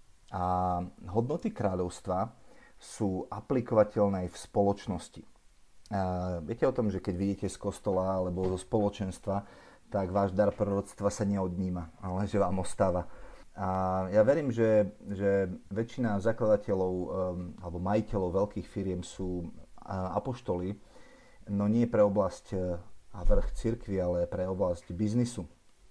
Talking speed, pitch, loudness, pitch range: 125 wpm, 100 Hz, -31 LUFS, 90-105 Hz